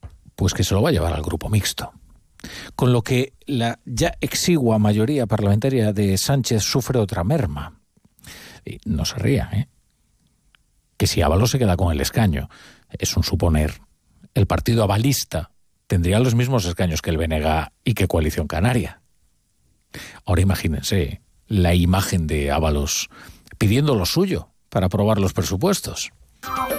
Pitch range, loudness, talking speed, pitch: 85-115 Hz, -21 LUFS, 150 wpm, 95 Hz